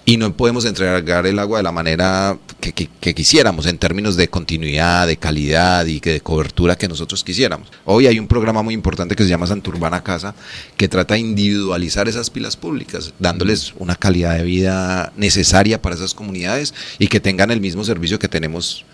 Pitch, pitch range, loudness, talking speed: 95 Hz, 85-105 Hz, -17 LUFS, 195 wpm